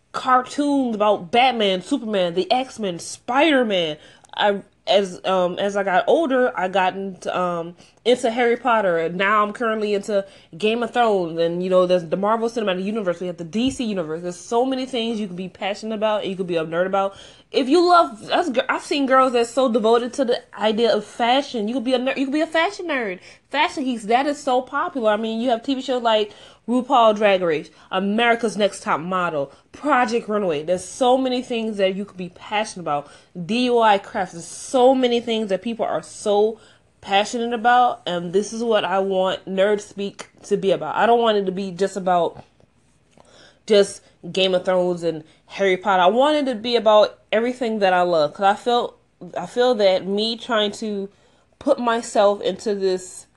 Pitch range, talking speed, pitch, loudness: 190-245 Hz, 195 wpm, 210 Hz, -20 LUFS